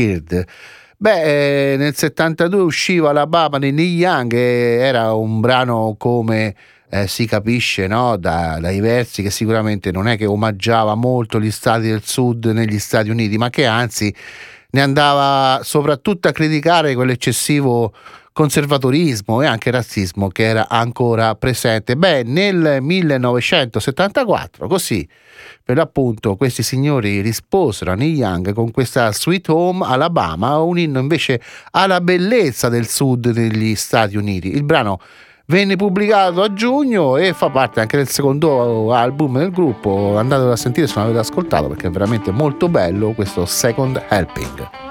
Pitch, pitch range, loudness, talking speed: 125 Hz, 110-150 Hz, -16 LUFS, 145 wpm